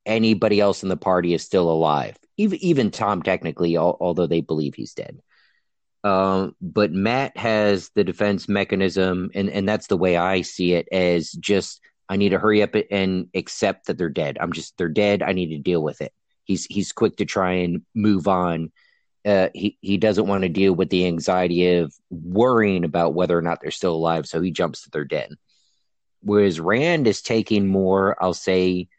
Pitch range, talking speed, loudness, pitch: 90-100 Hz, 195 wpm, -21 LUFS, 95 Hz